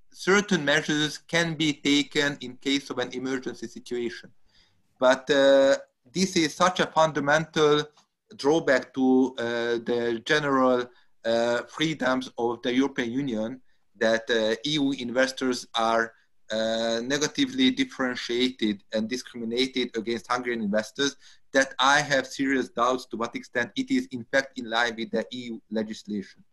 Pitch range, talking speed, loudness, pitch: 115-145 Hz, 135 wpm, -25 LUFS, 130 Hz